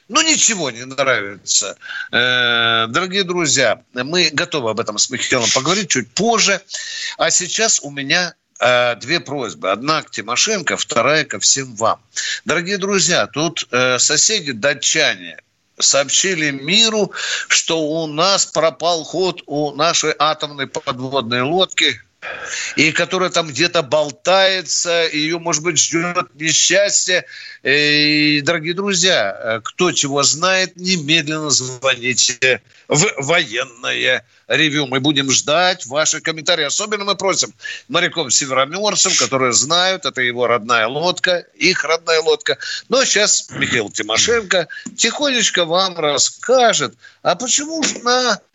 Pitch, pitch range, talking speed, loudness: 170 Hz, 145-195 Hz, 120 wpm, -15 LUFS